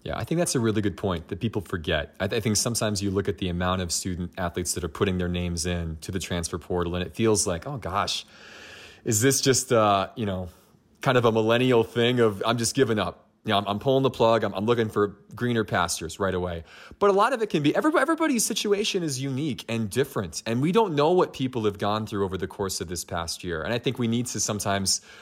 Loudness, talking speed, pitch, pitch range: -25 LUFS, 255 wpm, 110 Hz, 95-120 Hz